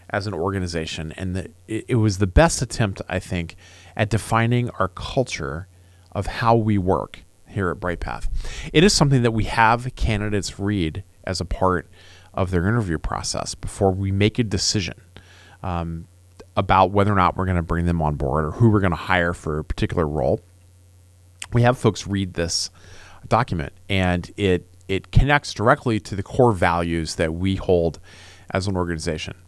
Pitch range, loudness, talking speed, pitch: 85-105 Hz, -22 LUFS, 180 wpm, 95 Hz